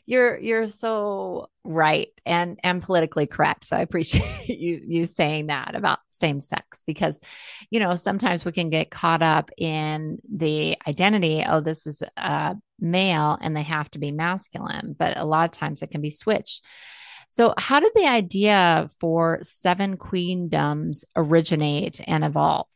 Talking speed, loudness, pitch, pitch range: 160 wpm, -23 LUFS, 170 Hz, 155-190 Hz